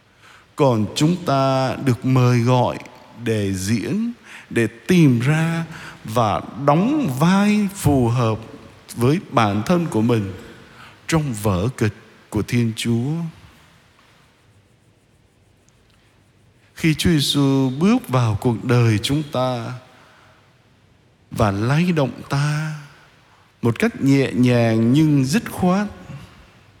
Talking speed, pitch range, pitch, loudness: 105 wpm, 115-150 Hz, 125 Hz, -19 LUFS